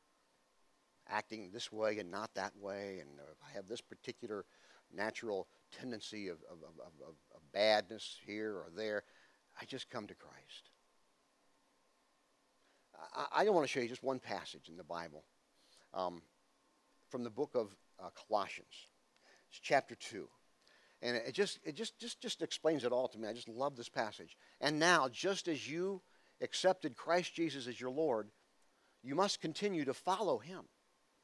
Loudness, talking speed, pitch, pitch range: -39 LUFS, 165 wpm, 125 Hz, 105-165 Hz